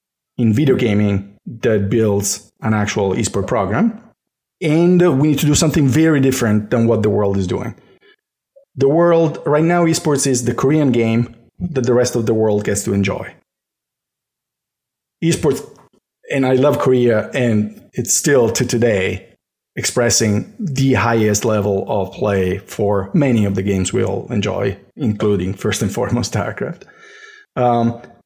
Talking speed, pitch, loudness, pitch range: 150 wpm, 120 Hz, -16 LUFS, 105-150 Hz